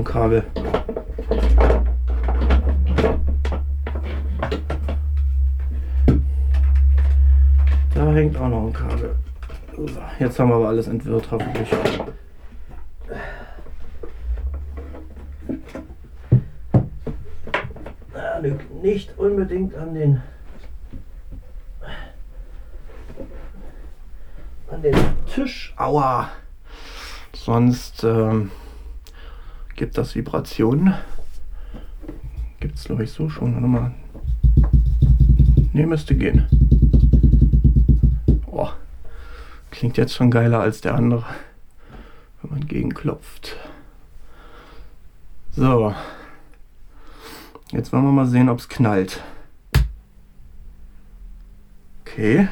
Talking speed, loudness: 70 wpm, -20 LUFS